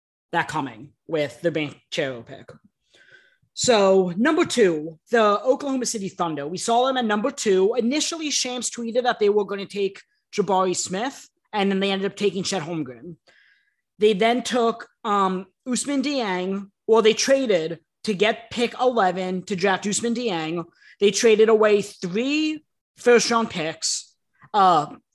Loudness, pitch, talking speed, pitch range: -22 LUFS, 210 Hz, 155 wpm, 185-245 Hz